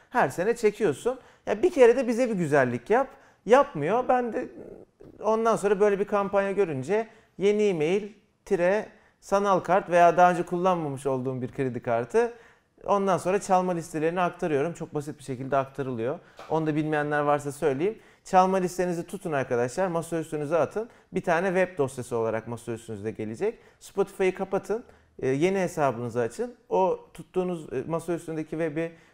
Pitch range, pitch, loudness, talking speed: 145-205 Hz, 180 Hz, -26 LUFS, 145 wpm